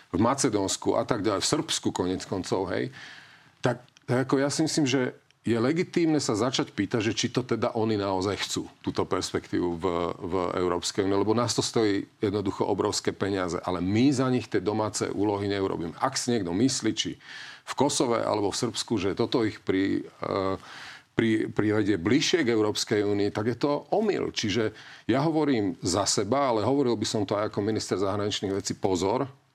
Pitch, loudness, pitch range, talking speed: 110 Hz, -27 LUFS, 100-135 Hz, 185 wpm